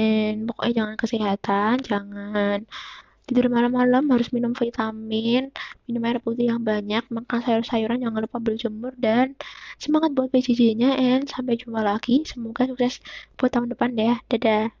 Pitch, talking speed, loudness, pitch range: 235 Hz, 150 wpm, -23 LUFS, 220-250 Hz